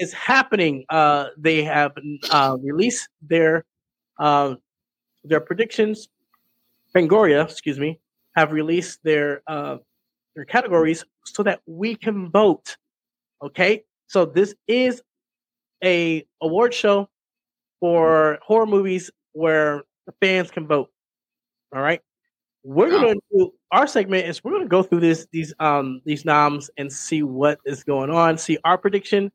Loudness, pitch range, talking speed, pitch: -20 LUFS, 150-205 Hz, 135 wpm, 165 Hz